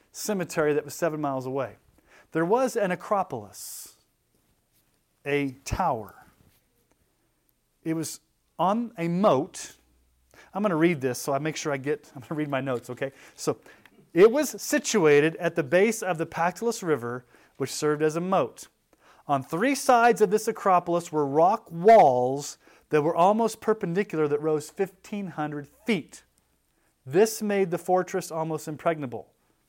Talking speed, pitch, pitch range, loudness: 150 wpm, 165 Hz, 145-195 Hz, -25 LUFS